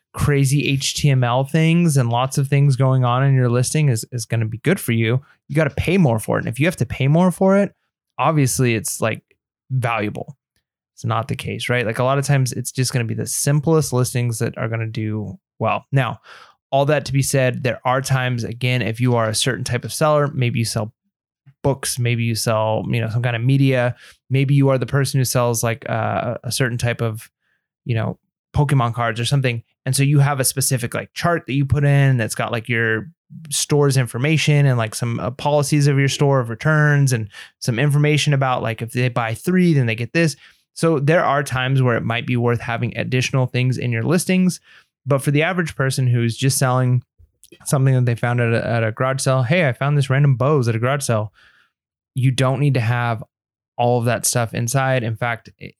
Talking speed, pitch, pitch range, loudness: 225 wpm, 130 Hz, 120-140 Hz, -19 LUFS